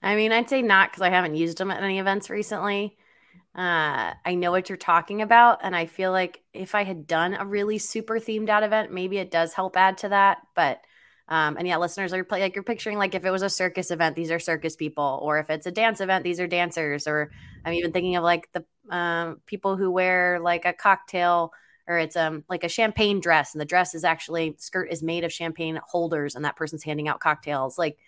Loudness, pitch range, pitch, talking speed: -24 LUFS, 165-195 Hz, 180 Hz, 235 wpm